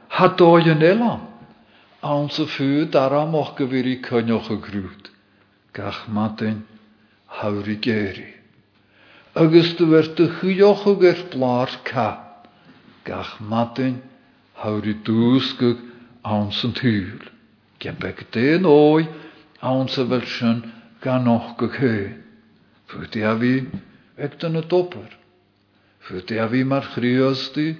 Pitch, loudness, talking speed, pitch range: 125 Hz, -20 LUFS, 95 wpm, 110-150 Hz